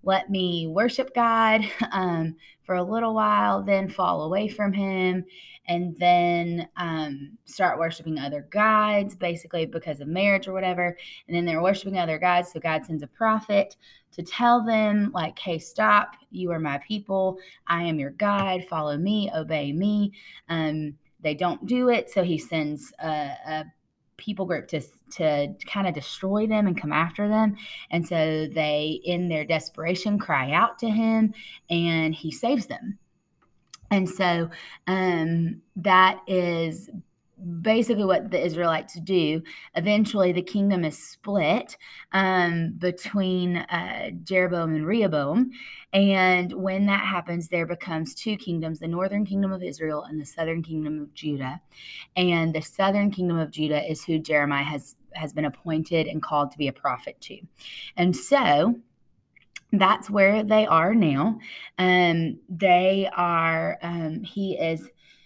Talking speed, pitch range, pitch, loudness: 155 wpm, 160-200 Hz, 180 Hz, -24 LUFS